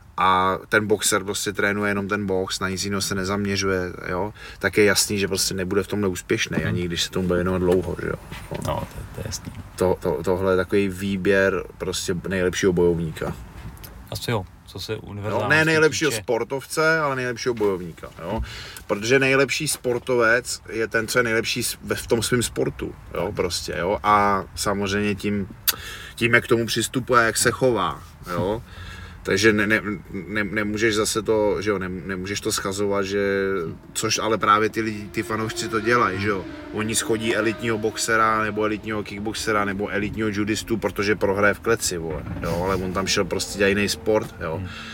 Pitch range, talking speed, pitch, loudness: 95-110 Hz, 175 wpm, 105 Hz, -22 LUFS